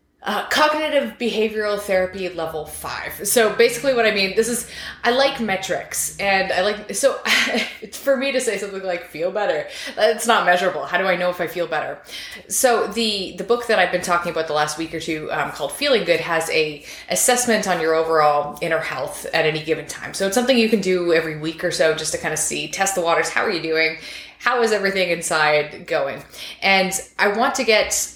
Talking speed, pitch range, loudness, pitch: 215 wpm, 165-230 Hz, -20 LUFS, 195 Hz